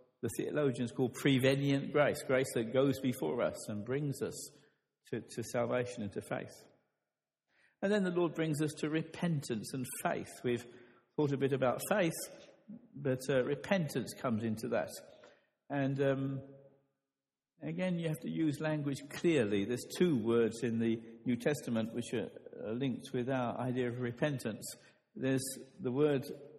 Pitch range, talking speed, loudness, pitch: 120-145 Hz, 155 wpm, -35 LUFS, 135 Hz